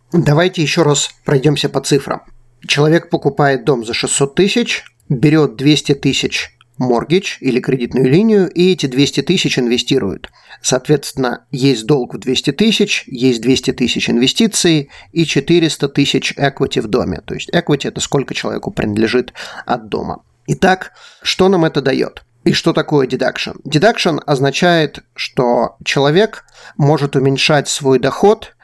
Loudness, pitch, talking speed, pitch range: -14 LUFS, 145 Hz, 140 wpm, 130-165 Hz